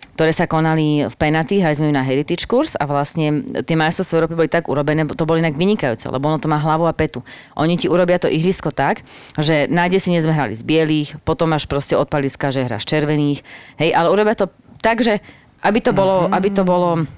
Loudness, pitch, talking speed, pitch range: -17 LUFS, 155 Hz, 215 wpm, 145-175 Hz